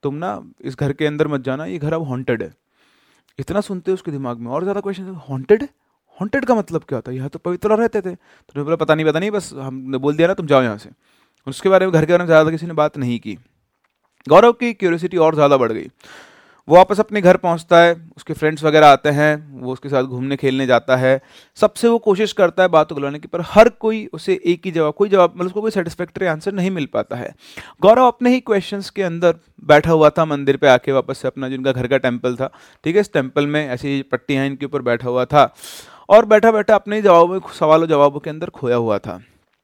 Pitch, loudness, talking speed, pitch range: 155 Hz, -16 LUFS, 240 wpm, 135-190 Hz